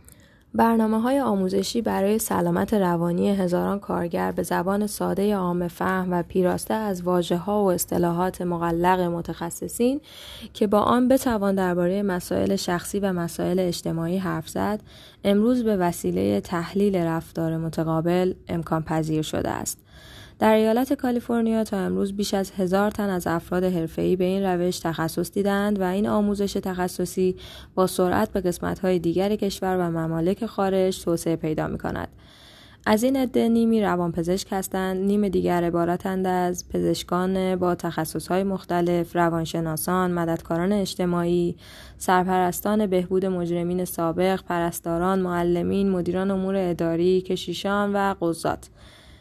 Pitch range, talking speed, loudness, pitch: 170-200 Hz, 130 wpm, -24 LUFS, 185 Hz